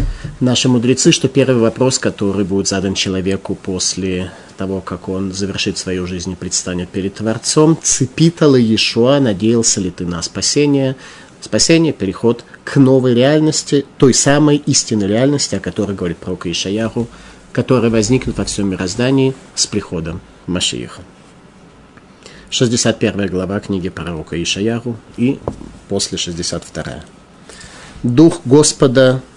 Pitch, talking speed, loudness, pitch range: 110 Hz, 120 wpm, -15 LUFS, 95-130 Hz